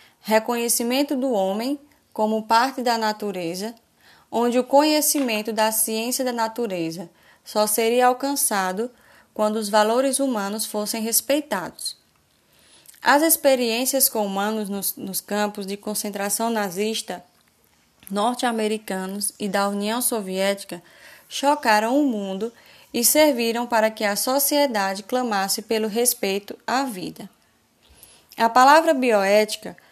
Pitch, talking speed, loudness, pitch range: 225 Hz, 110 wpm, -21 LUFS, 205-250 Hz